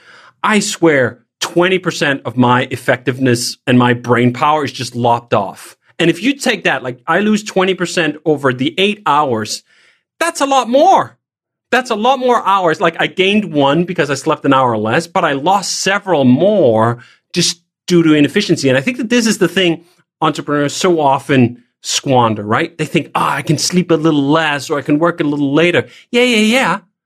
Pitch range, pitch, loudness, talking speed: 135-190 Hz, 165 Hz, -14 LUFS, 195 wpm